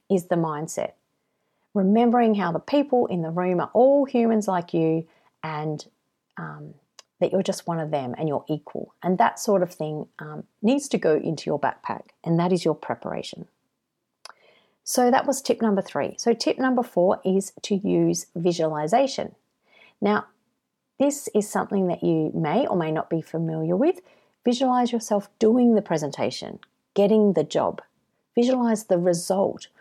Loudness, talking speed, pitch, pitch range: -23 LUFS, 165 wpm, 195 Hz, 165-235 Hz